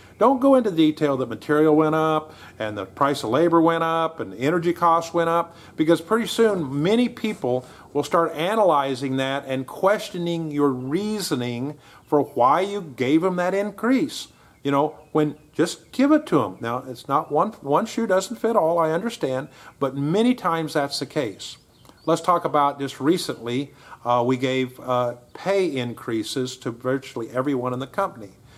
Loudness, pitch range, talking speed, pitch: -22 LUFS, 130-180 Hz, 175 wpm, 150 Hz